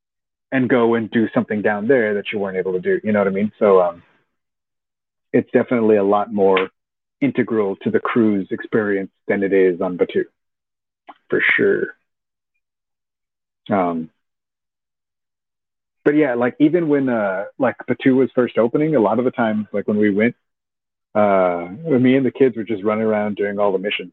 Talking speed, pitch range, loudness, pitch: 175 wpm, 100-125 Hz, -18 LUFS, 110 Hz